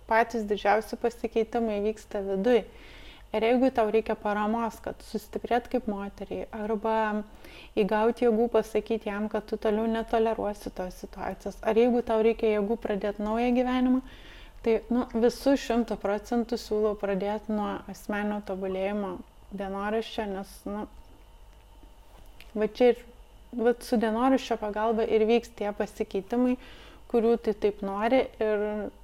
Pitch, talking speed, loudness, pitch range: 220 Hz, 120 wpm, -28 LUFS, 205-235 Hz